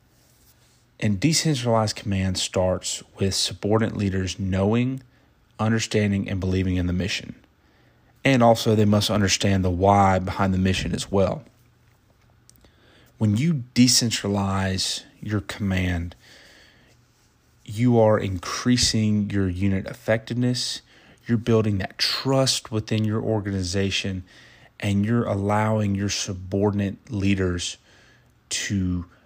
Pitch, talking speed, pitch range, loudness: 105 Hz, 105 wpm, 95-115 Hz, -23 LUFS